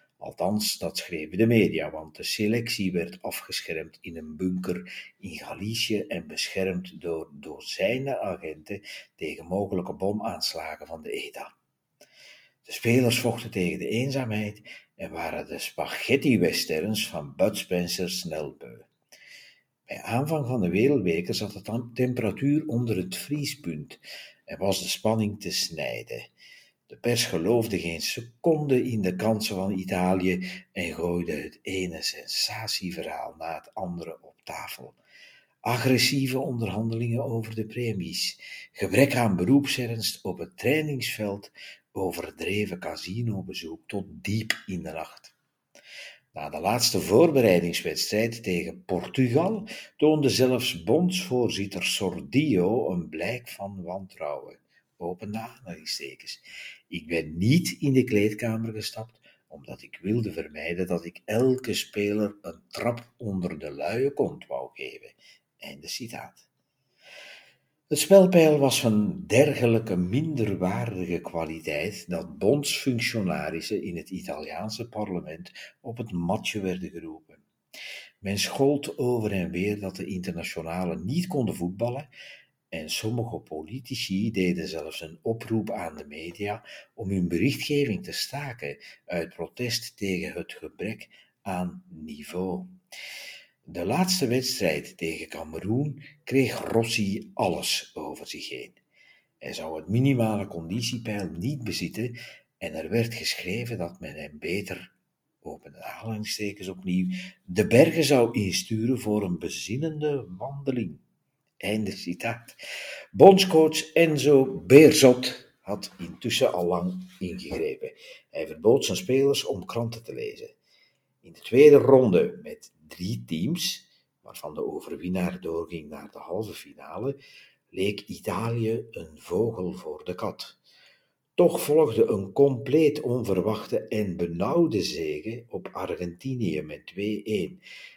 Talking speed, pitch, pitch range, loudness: 120 wpm, 115 Hz, 95-135 Hz, -26 LUFS